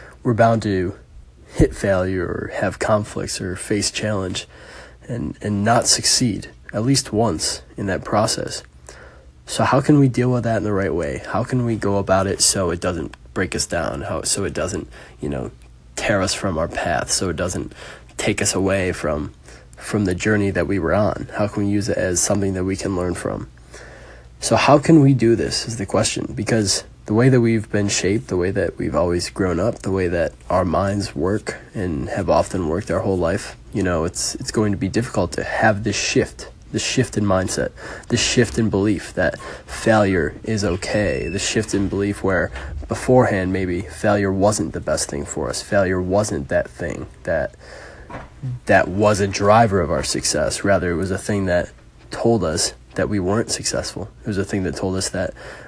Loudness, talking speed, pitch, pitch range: -20 LUFS, 200 wpm, 100 Hz, 90-110 Hz